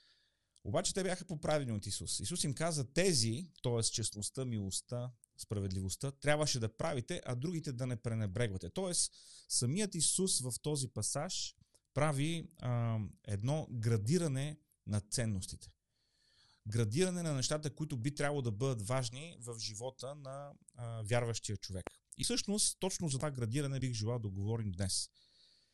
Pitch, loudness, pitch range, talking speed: 125 Hz, -37 LUFS, 110-150 Hz, 140 wpm